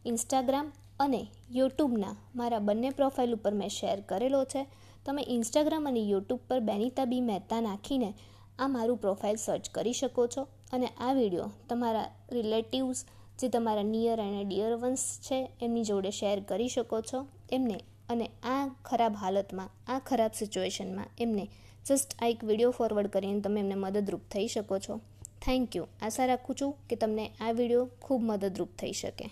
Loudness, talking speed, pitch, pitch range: -32 LUFS, 160 wpm, 230 Hz, 205-255 Hz